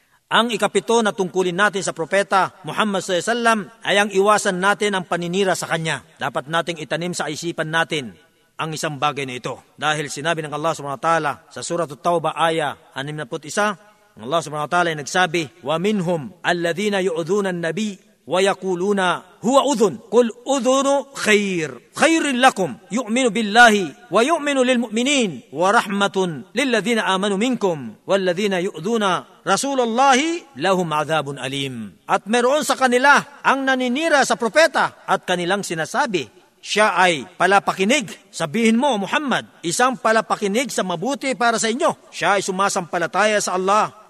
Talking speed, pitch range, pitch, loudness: 135 wpm, 165-230 Hz, 195 Hz, -19 LUFS